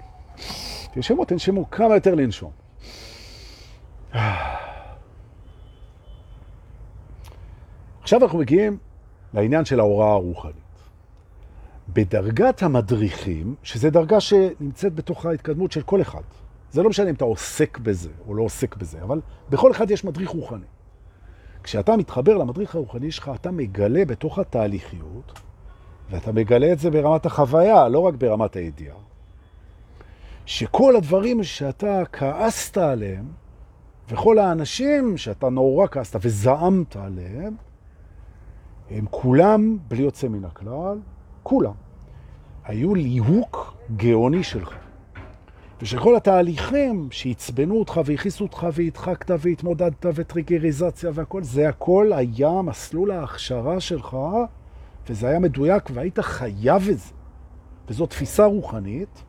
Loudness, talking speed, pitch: -21 LUFS, 110 wpm, 125 Hz